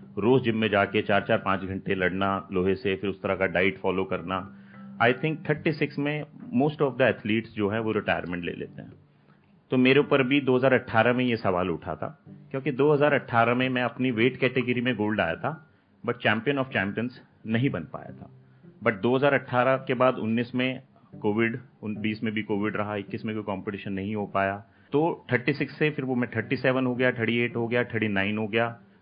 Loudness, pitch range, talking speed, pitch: -26 LUFS, 100-130 Hz, 220 wpm, 115 Hz